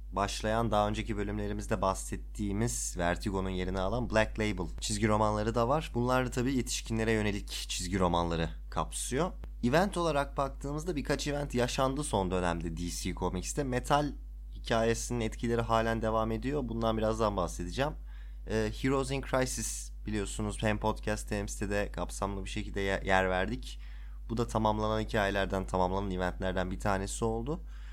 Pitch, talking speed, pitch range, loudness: 105 Hz, 140 wpm, 95-120 Hz, -32 LUFS